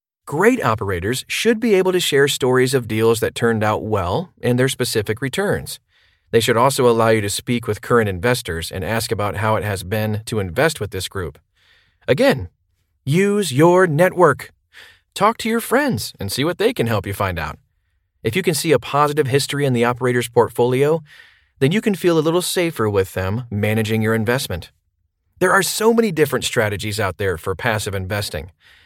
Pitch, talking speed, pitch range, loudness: 120 Hz, 190 wpm, 100-150 Hz, -18 LUFS